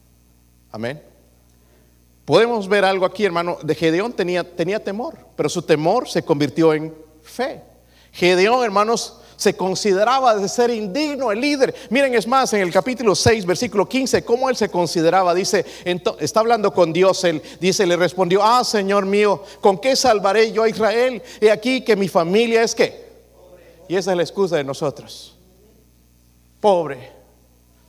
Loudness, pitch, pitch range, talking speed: -18 LUFS, 195 Hz, 160-225 Hz, 160 wpm